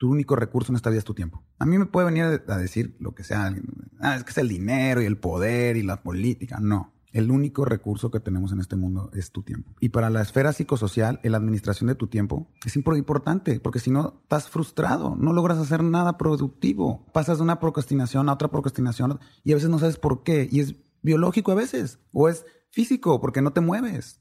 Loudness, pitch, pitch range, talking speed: -24 LUFS, 130 Hz, 110-155 Hz, 225 wpm